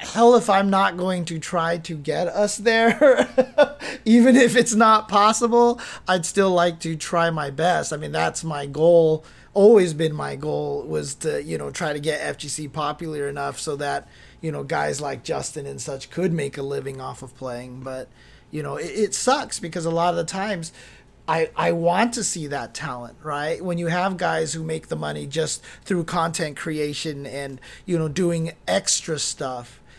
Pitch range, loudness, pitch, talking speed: 145-195 Hz, -22 LUFS, 165 Hz, 190 wpm